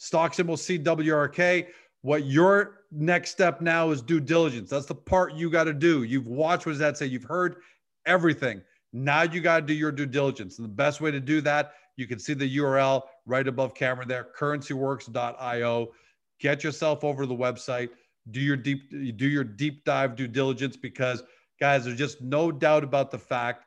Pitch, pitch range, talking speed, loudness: 145 Hz, 130-160 Hz, 195 wpm, -26 LUFS